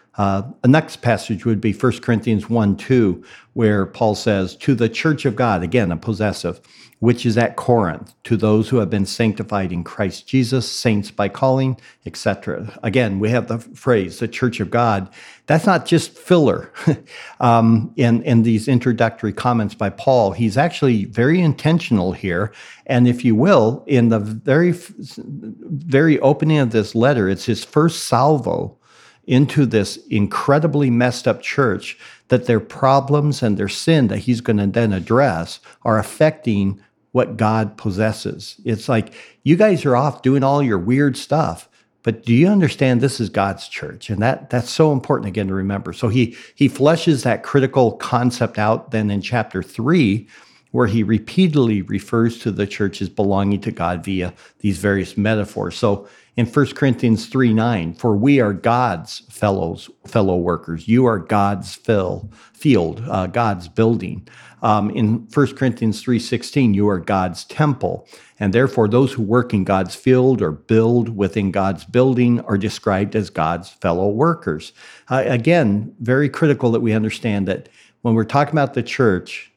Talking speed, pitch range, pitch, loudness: 165 wpm, 105-130 Hz, 115 Hz, -18 LUFS